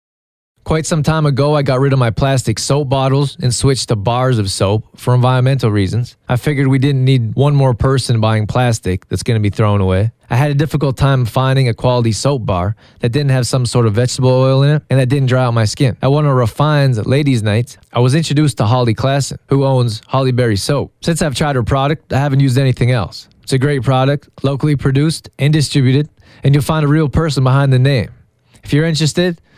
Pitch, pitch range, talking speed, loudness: 130 Hz, 120-140 Hz, 225 wpm, -14 LUFS